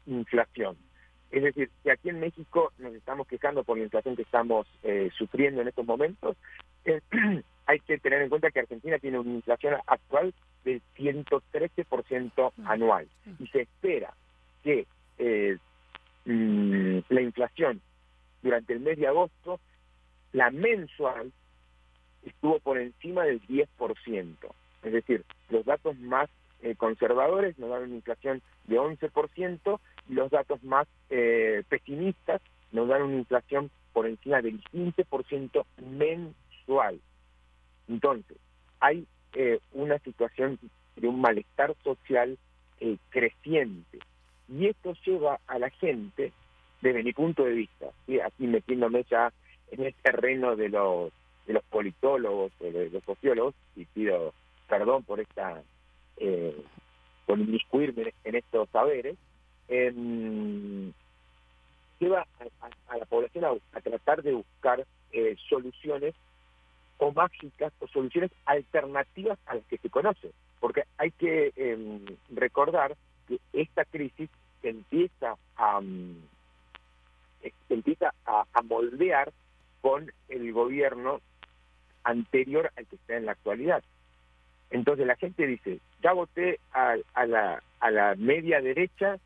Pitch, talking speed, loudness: 125 Hz, 130 wpm, -29 LUFS